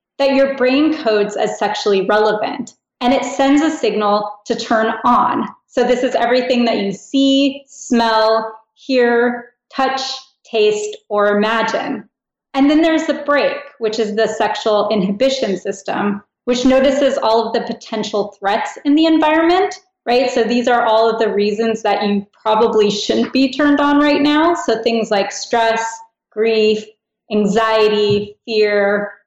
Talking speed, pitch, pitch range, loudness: 150 wpm, 230 Hz, 215-275 Hz, -16 LUFS